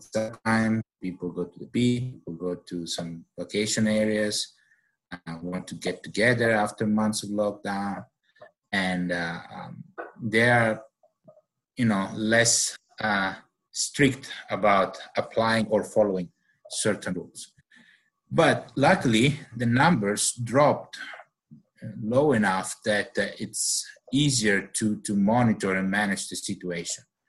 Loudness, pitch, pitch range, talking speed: -25 LUFS, 110 Hz, 95-115 Hz, 125 wpm